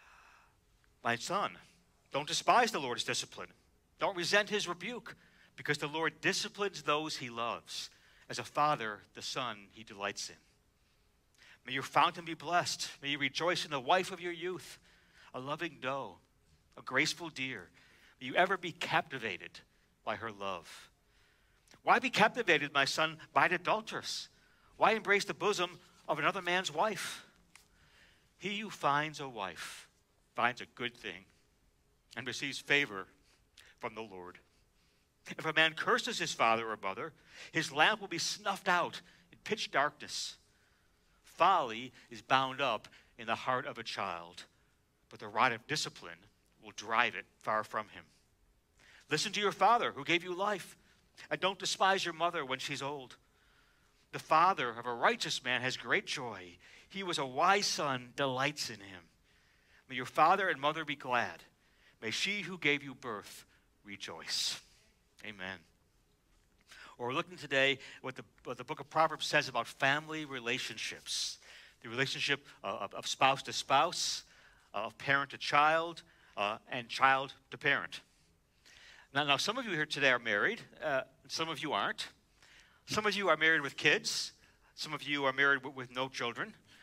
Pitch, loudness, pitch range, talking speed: 140 Hz, -33 LUFS, 115-170 Hz, 160 wpm